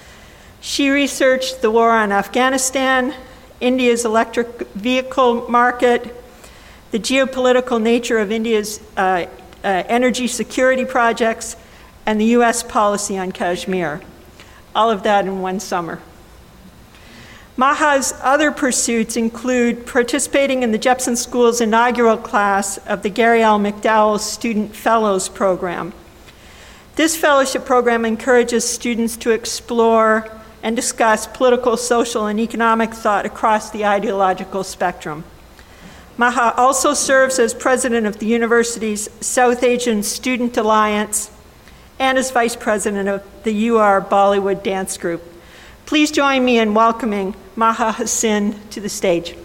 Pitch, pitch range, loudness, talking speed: 230 Hz, 210-250 Hz, -17 LUFS, 125 wpm